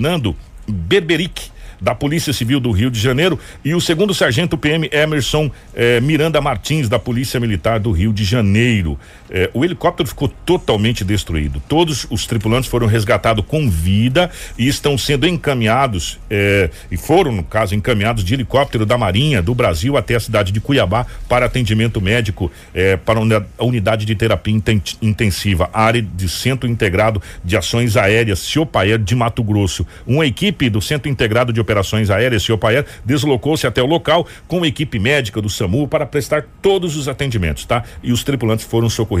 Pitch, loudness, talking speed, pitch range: 115 Hz, -16 LUFS, 170 wpm, 105-145 Hz